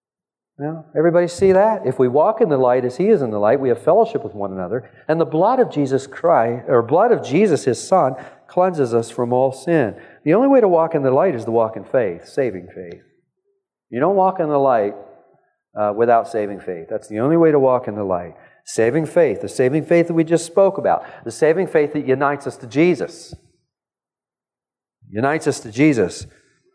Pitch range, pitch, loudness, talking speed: 120-170 Hz, 145 Hz, -18 LUFS, 215 wpm